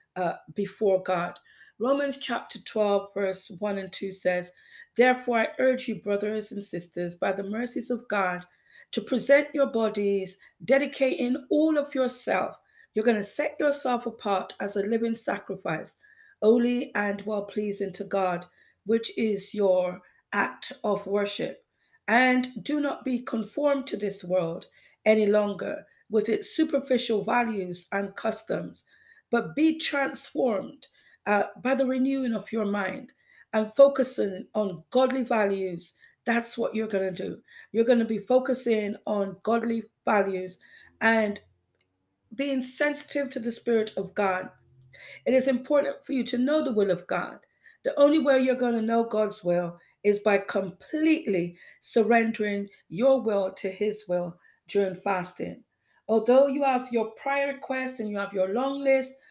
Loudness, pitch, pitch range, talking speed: -27 LUFS, 220 Hz, 200-260 Hz, 150 wpm